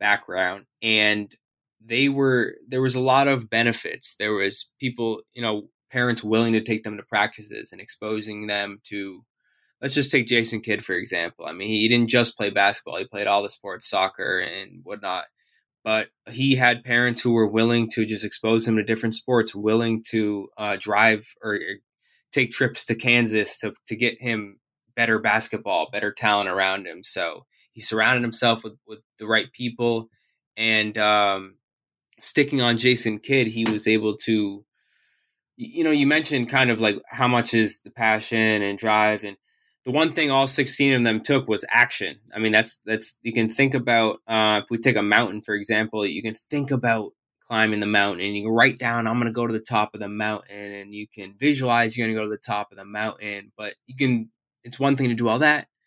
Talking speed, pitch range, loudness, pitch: 200 wpm, 105-120 Hz, -21 LUFS, 110 Hz